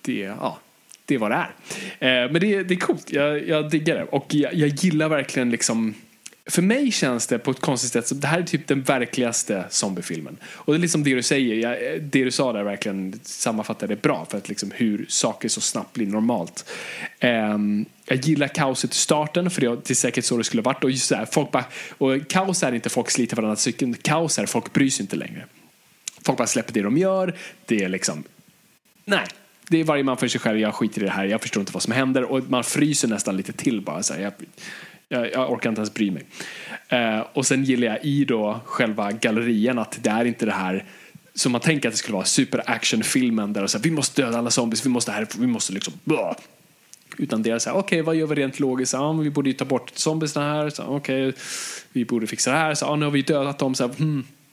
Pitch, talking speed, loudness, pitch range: 135 Hz, 250 wpm, -23 LUFS, 120-150 Hz